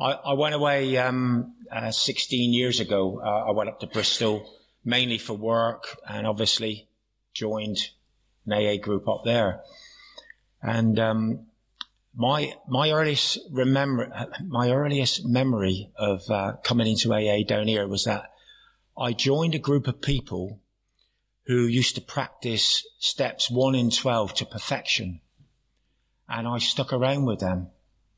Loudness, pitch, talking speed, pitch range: -25 LUFS, 115 Hz, 140 wpm, 105-130 Hz